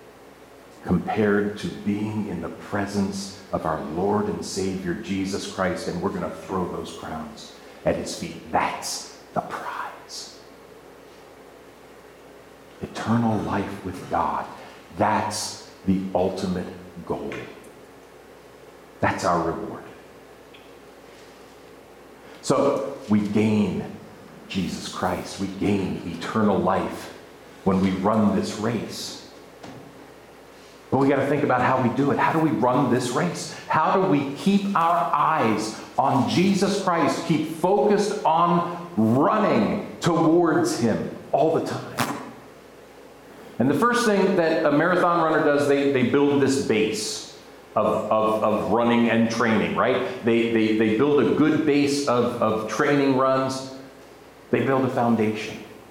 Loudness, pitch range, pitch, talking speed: -23 LUFS, 110-160 Hz, 130 Hz, 130 wpm